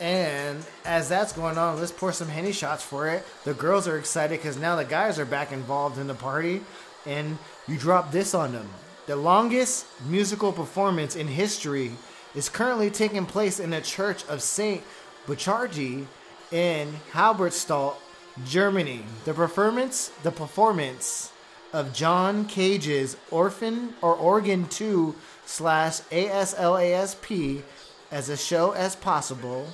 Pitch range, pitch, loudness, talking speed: 145-190 Hz, 170 Hz, -26 LUFS, 150 wpm